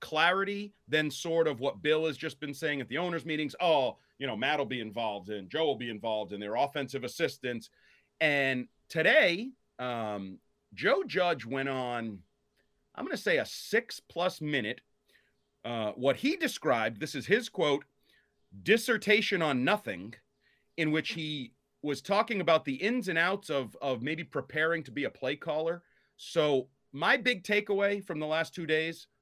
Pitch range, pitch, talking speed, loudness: 130-180 Hz, 155 Hz, 170 wpm, -31 LUFS